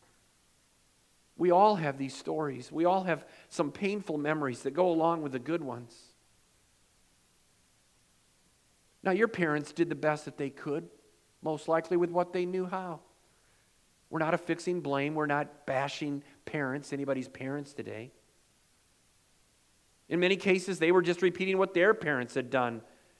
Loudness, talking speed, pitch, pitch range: -31 LUFS, 145 wpm, 155 Hz, 140-180 Hz